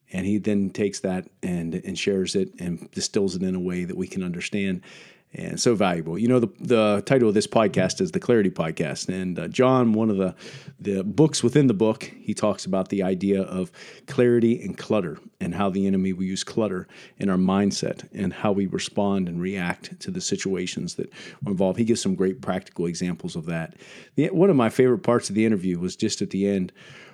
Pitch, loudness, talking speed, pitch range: 100 Hz, -24 LUFS, 215 wpm, 95-115 Hz